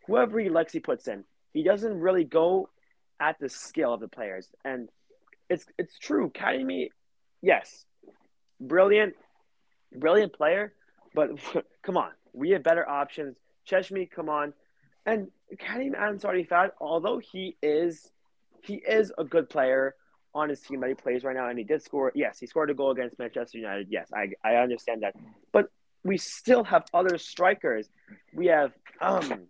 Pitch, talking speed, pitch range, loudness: 165 Hz, 165 wpm, 140-200 Hz, -28 LUFS